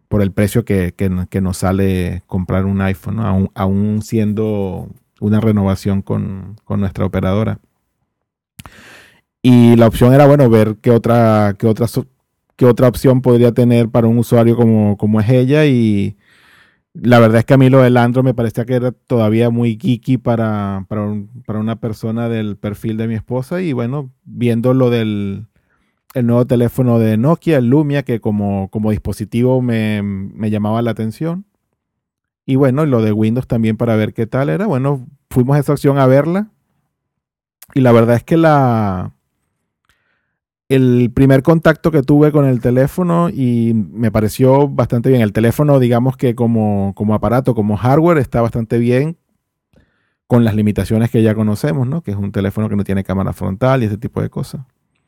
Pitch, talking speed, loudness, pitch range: 115 Hz, 175 wpm, -14 LUFS, 105-130 Hz